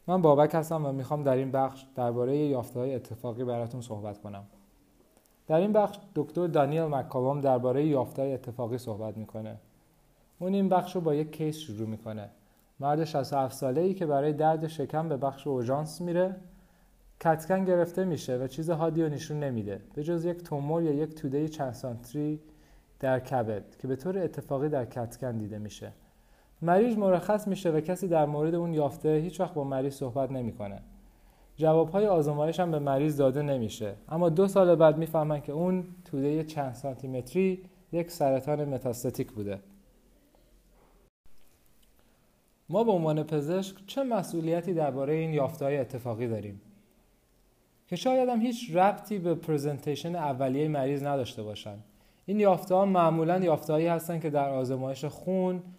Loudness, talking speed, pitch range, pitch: -29 LUFS, 155 wpm, 130-170 Hz, 150 Hz